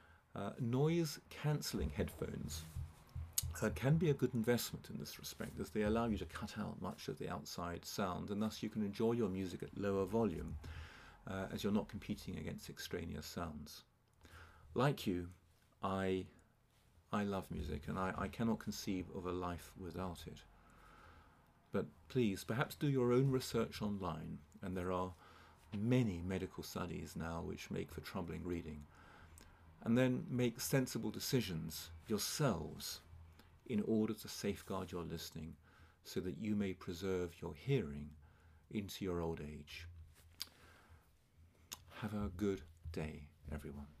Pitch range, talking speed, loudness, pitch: 80-105 Hz, 145 wpm, -41 LUFS, 90 Hz